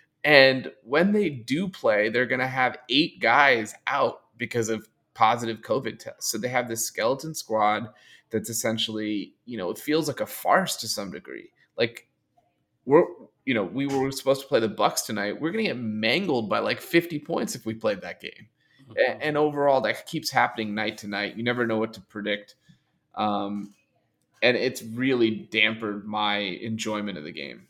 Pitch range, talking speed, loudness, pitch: 105-135 Hz, 185 wpm, -25 LUFS, 115 Hz